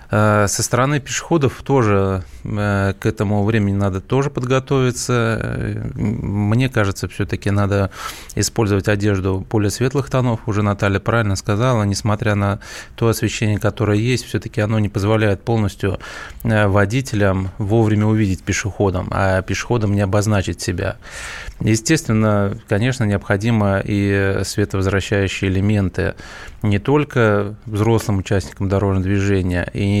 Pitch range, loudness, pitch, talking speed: 100-115 Hz, -18 LUFS, 105 Hz, 110 wpm